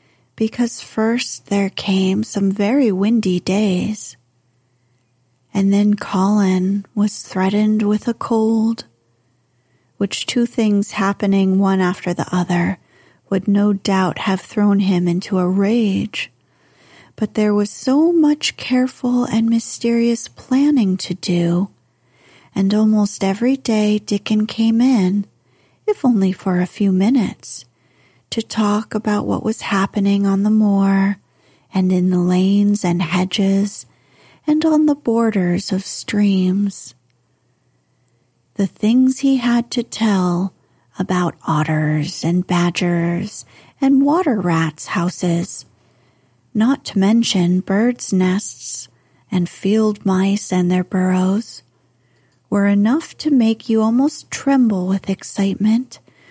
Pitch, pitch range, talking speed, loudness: 200 Hz, 180-220 Hz, 120 wpm, -17 LUFS